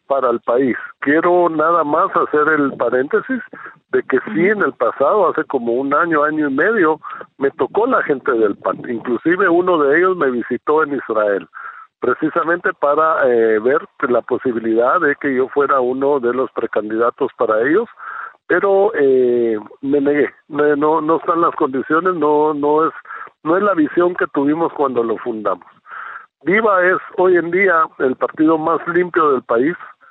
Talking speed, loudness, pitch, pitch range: 165 wpm, -16 LUFS, 155 Hz, 140-175 Hz